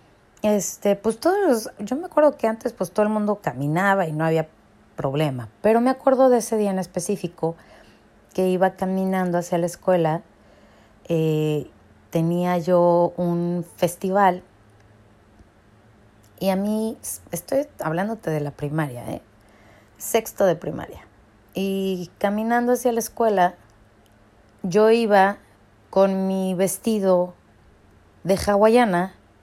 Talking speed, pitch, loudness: 125 wpm, 180 Hz, -22 LUFS